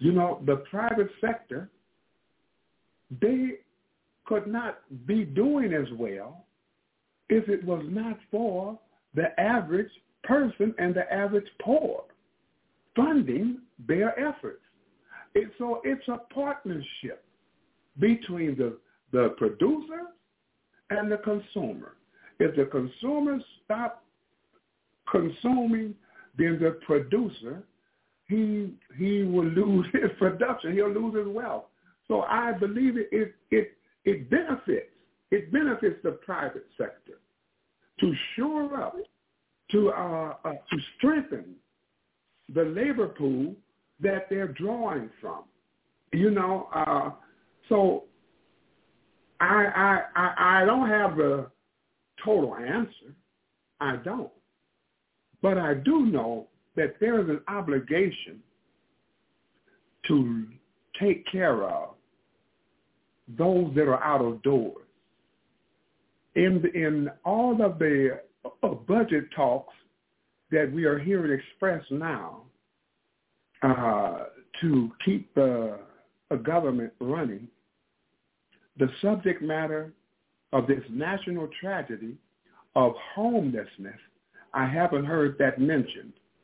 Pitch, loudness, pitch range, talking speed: 195 Hz, -27 LUFS, 155-225 Hz, 105 wpm